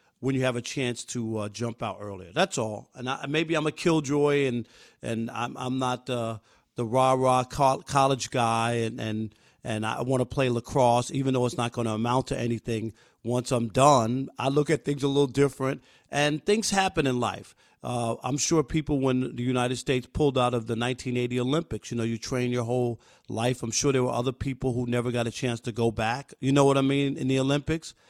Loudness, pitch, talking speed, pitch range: -27 LUFS, 125 Hz, 225 wpm, 120-140 Hz